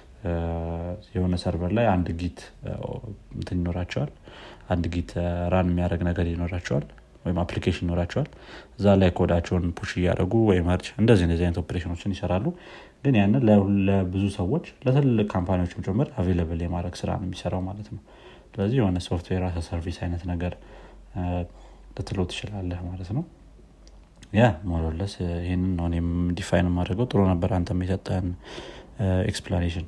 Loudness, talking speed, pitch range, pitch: -26 LUFS, 125 wpm, 85-100 Hz, 90 Hz